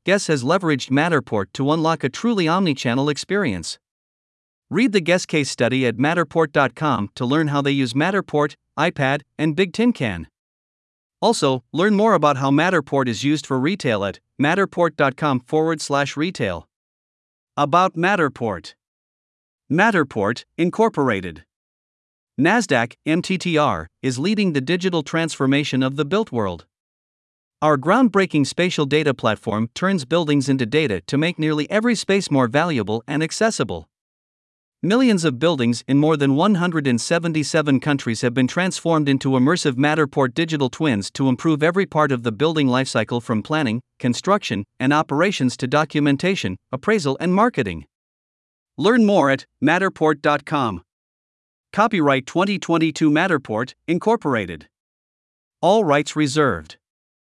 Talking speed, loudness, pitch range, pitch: 130 wpm, -19 LUFS, 130-170 Hz, 150 Hz